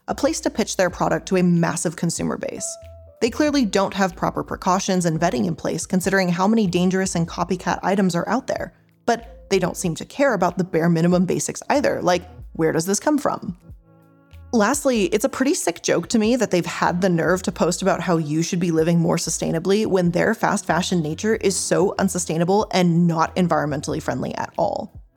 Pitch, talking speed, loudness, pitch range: 185 Hz, 205 wpm, -21 LUFS, 170-200 Hz